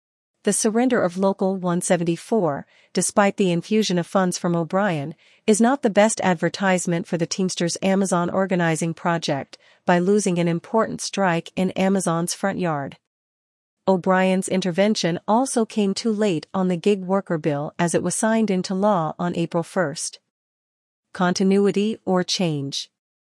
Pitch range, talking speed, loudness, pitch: 170-205 Hz, 140 wpm, -21 LUFS, 185 Hz